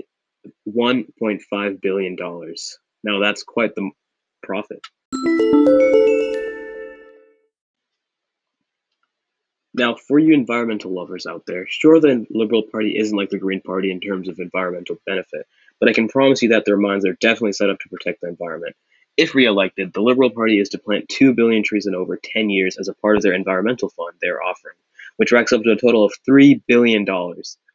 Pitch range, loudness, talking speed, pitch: 100-140 Hz, -18 LUFS, 170 wpm, 110 Hz